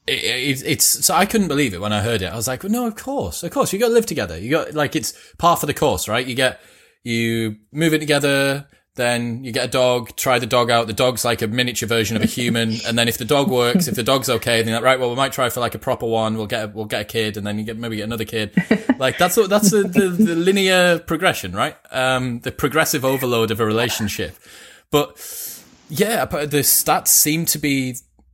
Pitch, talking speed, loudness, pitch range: 125 Hz, 255 wpm, -19 LUFS, 115-160 Hz